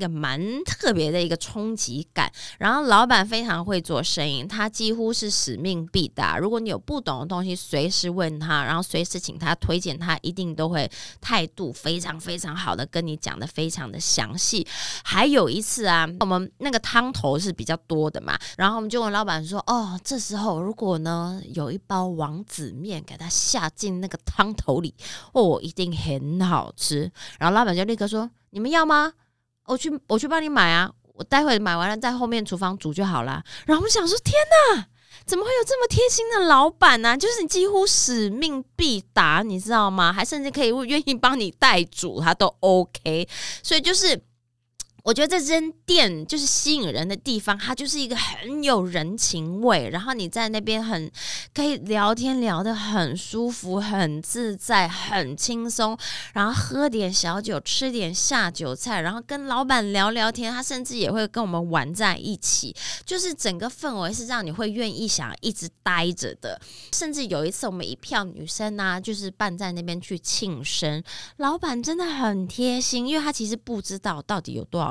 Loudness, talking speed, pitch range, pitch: -23 LUFS, 280 characters per minute, 170-245 Hz, 205 Hz